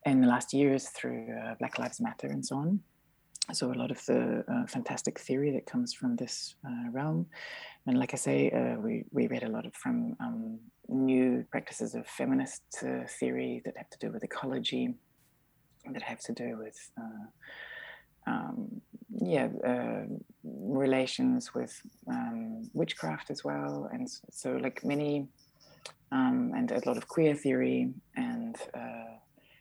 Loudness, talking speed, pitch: -33 LUFS, 160 wpm, 165 Hz